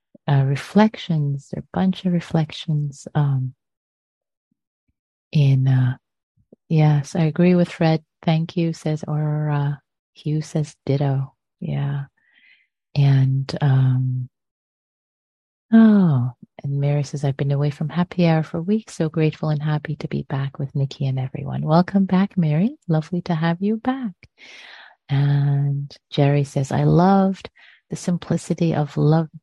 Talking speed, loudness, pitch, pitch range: 135 wpm, -21 LUFS, 150 Hz, 140-170 Hz